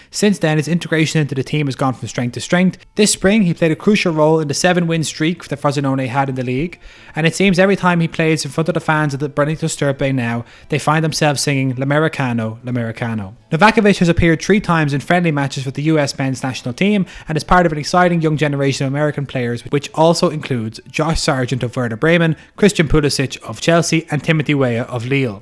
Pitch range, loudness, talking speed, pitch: 135-165 Hz, -16 LUFS, 225 wpm, 150 Hz